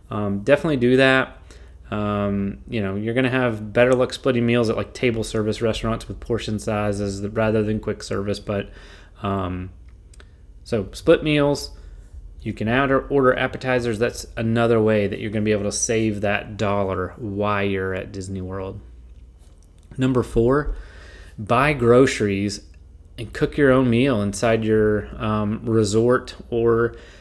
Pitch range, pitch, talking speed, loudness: 100-120 Hz, 110 Hz, 155 wpm, -21 LUFS